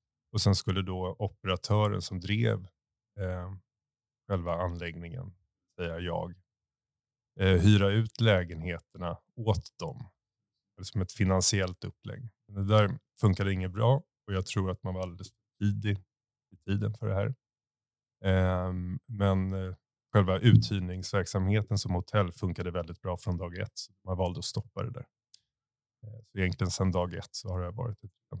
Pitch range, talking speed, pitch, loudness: 90-110 Hz, 155 wpm, 100 Hz, -30 LUFS